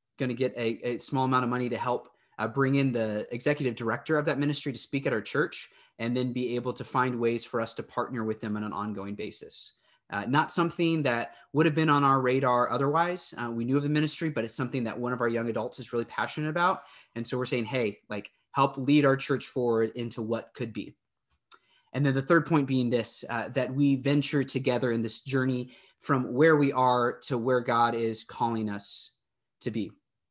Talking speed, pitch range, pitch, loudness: 225 wpm, 115-140 Hz, 125 Hz, -28 LUFS